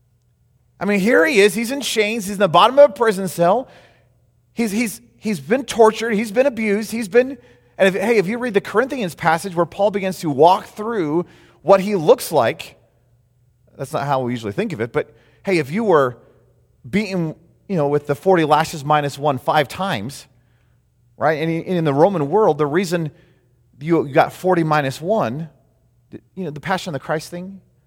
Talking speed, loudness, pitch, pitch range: 195 wpm, -18 LUFS, 170 Hz, 140-205 Hz